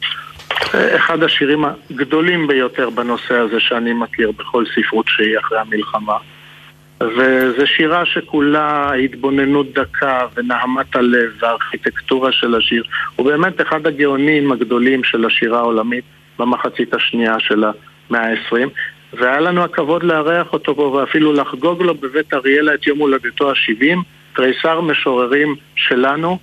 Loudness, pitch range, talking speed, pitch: -15 LUFS, 120-150 Hz, 125 wpm, 135 Hz